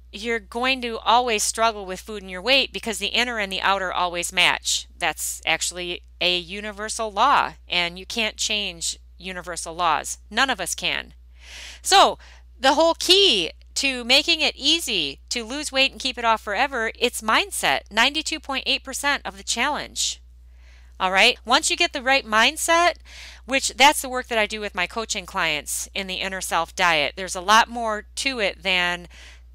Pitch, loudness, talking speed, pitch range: 210 Hz, -21 LUFS, 175 wpm, 175-255 Hz